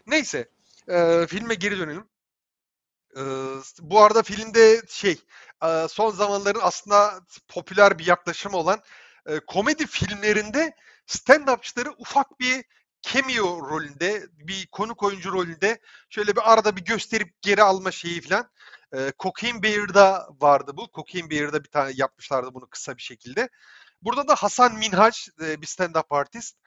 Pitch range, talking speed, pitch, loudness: 160-220 Hz, 135 wpm, 195 Hz, -22 LUFS